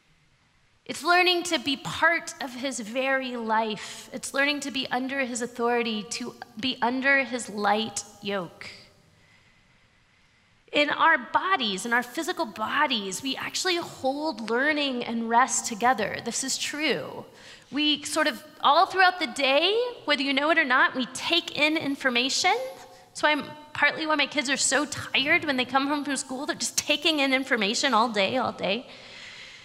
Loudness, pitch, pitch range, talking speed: -25 LUFS, 270 Hz, 235-305 Hz, 160 wpm